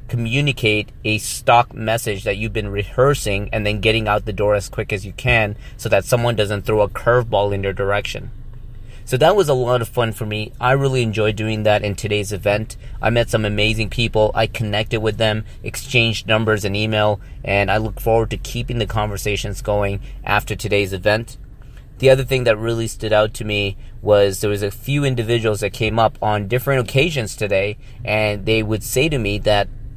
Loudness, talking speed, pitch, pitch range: -19 LUFS, 200 wpm, 110 Hz, 105-120 Hz